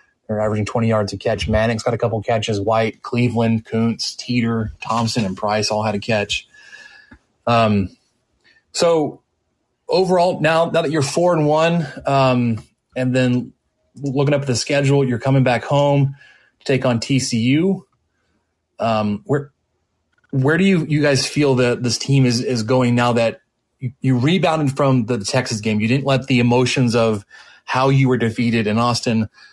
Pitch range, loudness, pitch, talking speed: 115-140 Hz, -18 LUFS, 125 Hz, 165 wpm